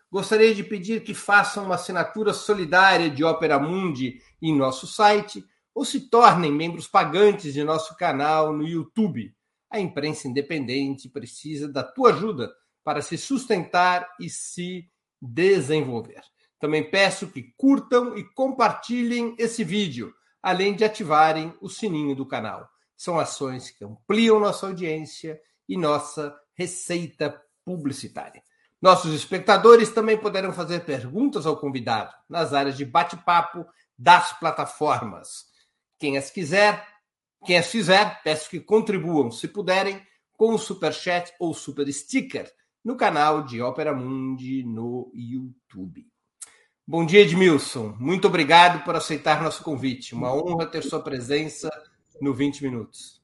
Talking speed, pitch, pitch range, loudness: 135 wpm, 165 Hz, 145-200 Hz, -22 LUFS